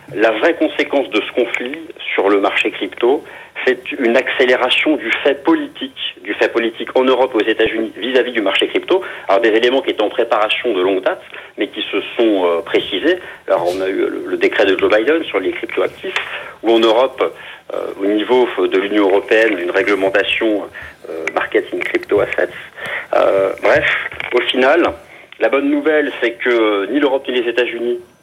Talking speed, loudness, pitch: 185 wpm, -16 LUFS, 325 Hz